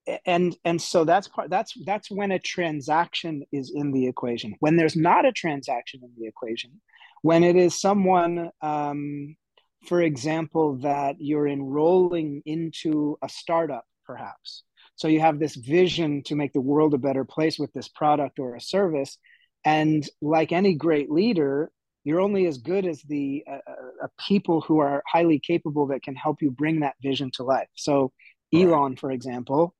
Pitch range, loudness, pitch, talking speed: 140-170 Hz, -24 LUFS, 155 Hz, 170 wpm